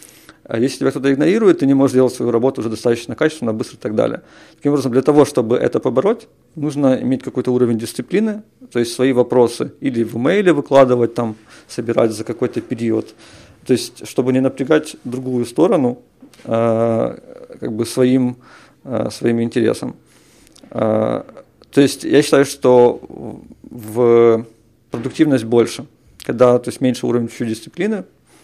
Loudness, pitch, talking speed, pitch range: -17 LUFS, 125 Hz, 150 wpm, 115-135 Hz